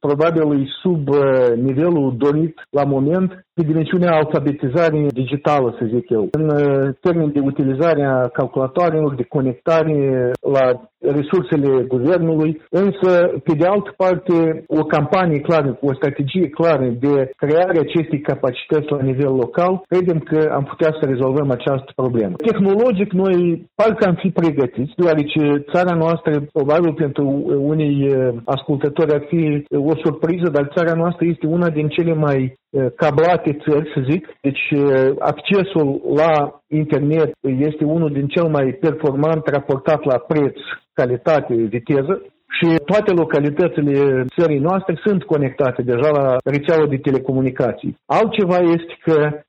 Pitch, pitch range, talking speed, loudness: 150 Hz, 140-170 Hz, 130 wpm, -17 LUFS